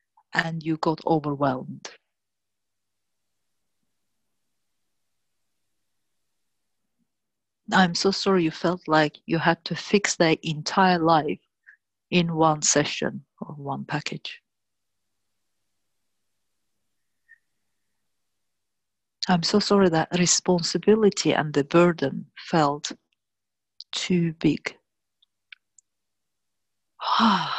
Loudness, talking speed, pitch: -23 LUFS, 75 wpm, 145 Hz